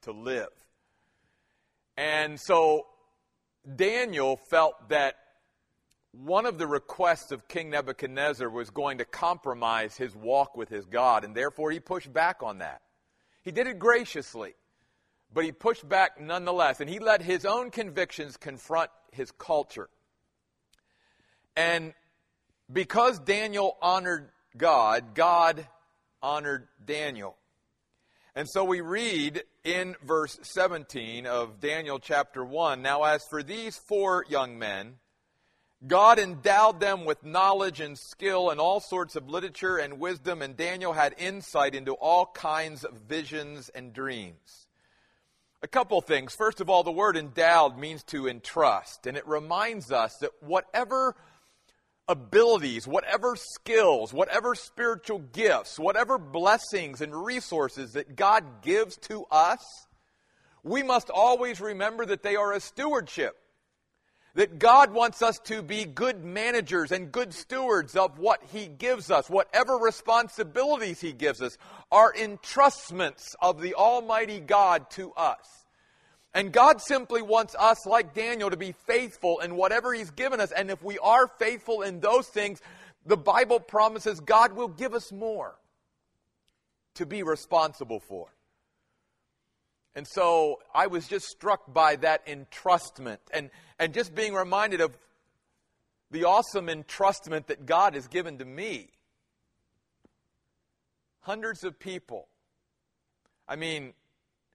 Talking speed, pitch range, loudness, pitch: 135 wpm, 150-220 Hz, -26 LUFS, 180 Hz